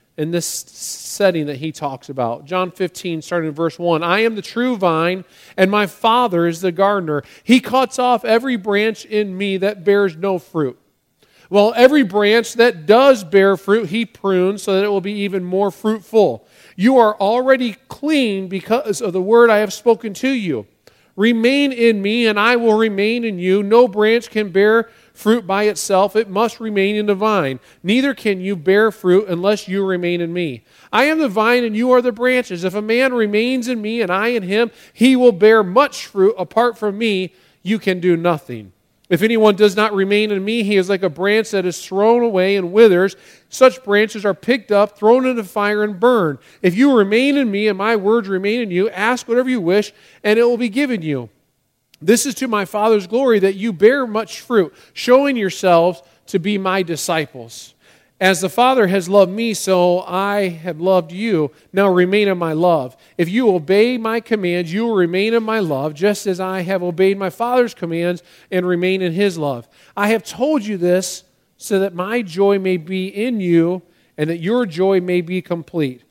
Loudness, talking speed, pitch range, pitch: -16 LUFS, 200 wpm, 185-230 Hz, 205 Hz